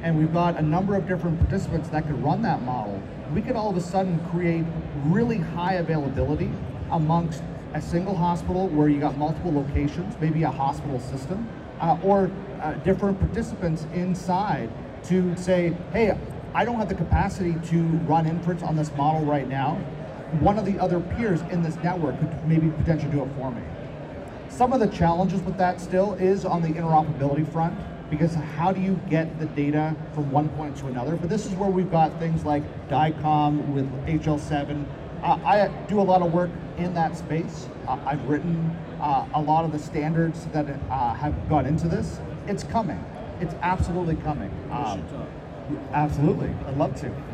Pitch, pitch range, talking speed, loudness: 160 Hz, 150-180 Hz, 180 wpm, -25 LUFS